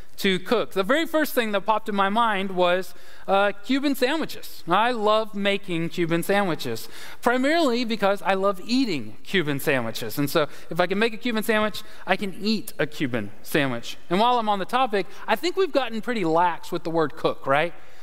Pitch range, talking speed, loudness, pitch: 175-235 Hz, 195 wpm, -24 LUFS, 200 Hz